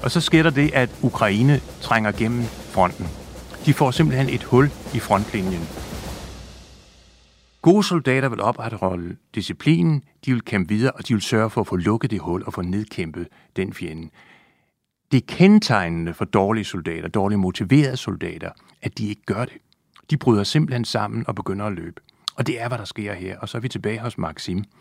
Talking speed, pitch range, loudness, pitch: 185 wpm, 95-130 Hz, -21 LUFS, 110 Hz